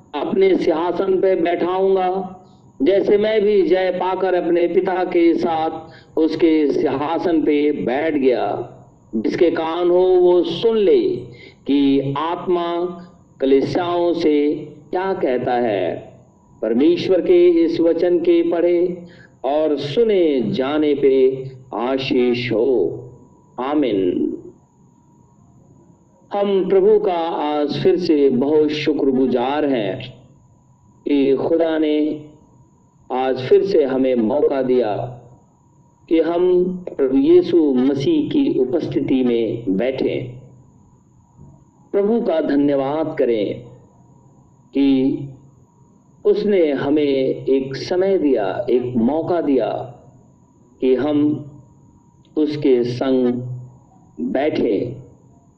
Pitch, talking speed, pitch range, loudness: 160 Hz, 95 wpm, 135-185 Hz, -18 LUFS